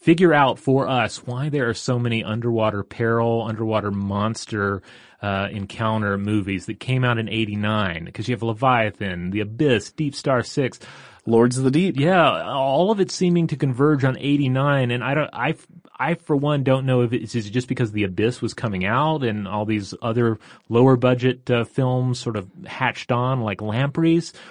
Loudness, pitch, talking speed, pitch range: -21 LUFS, 120 Hz, 185 wpm, 110-135 Hz